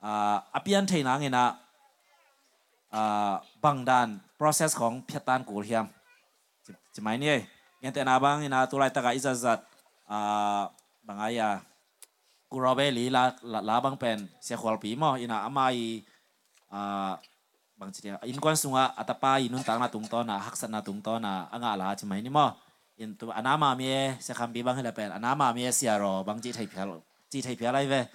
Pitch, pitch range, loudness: 120 Hz, 105-130 Hz, -29 LUFS